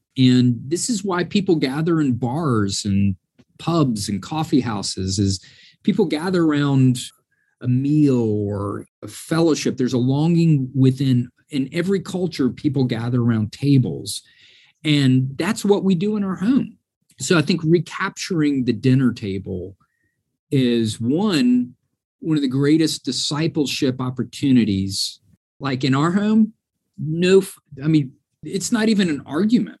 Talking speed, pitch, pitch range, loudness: 135 wpm, 140 Hz, 125-170 Hz, -20 LUFS